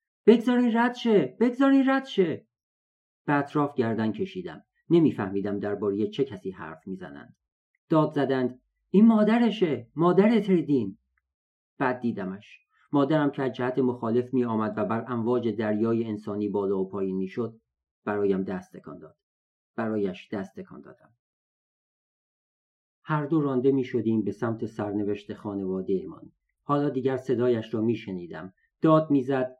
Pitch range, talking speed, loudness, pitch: 100-145 Hz, 135 wpm, -26 LUFS, 120 Hz